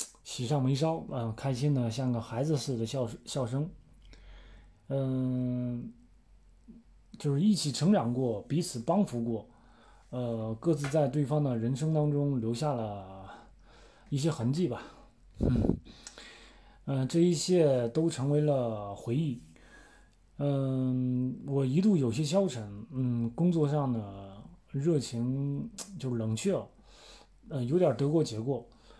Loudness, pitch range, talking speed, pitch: -31 LUFS, 115-150 Hz, 180 characters per minute, 130 Hz